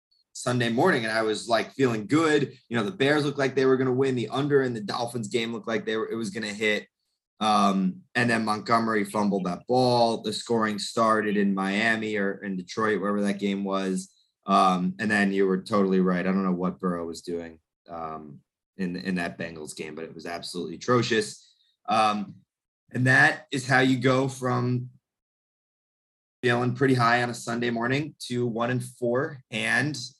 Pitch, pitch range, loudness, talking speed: 115 Hz, 95-125 Hz, -25 LUFS, 195 wpm